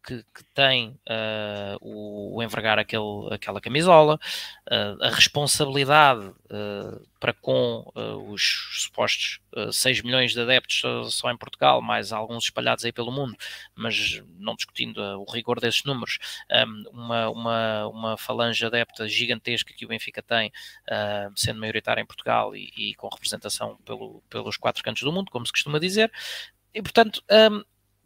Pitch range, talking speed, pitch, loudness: 110-135 Hz, 160 wpm, 115 Hz, -24 LUFS